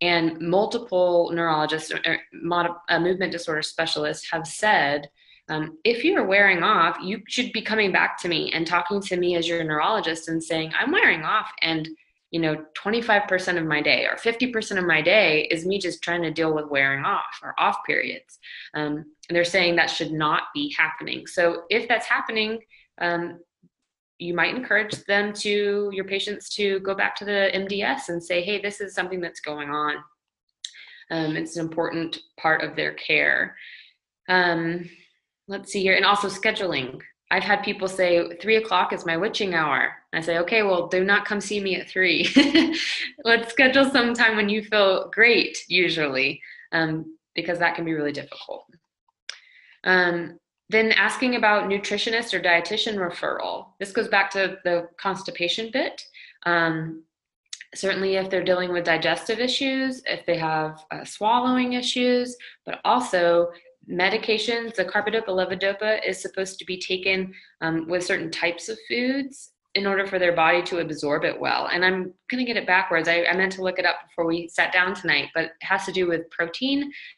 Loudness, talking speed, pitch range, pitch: -23 LUFS, 180 wpm, 165-210 Hz, 185 Hz